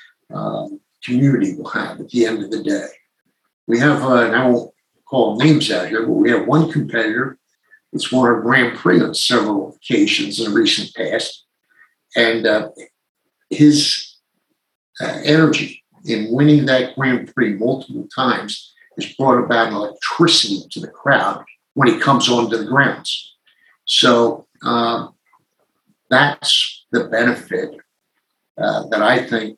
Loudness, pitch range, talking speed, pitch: -16 LUFS, 120-155 Hz, 145 wpm, 130 Hz